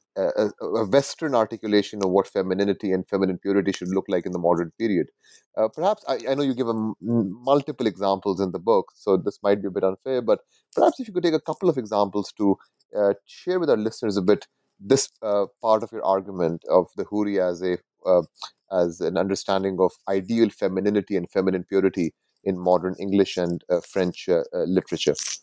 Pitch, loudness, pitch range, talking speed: 100 Hz, -24 LUFS, 95-115 Hz, 205 wpm